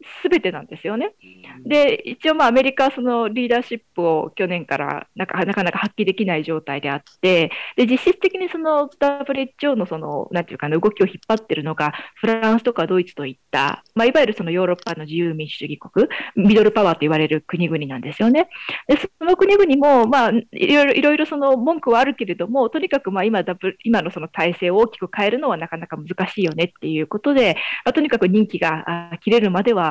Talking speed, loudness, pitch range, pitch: 425 characters per minute, -19 LUFS, 170-265 Hz, 210 Hz